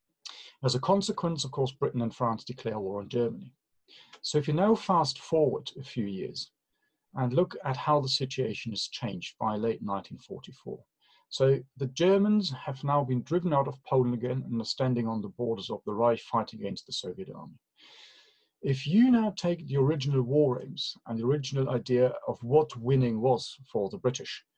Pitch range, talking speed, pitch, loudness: 120-150 Hz, 185 wpm, 130 Hz, -29 LUFS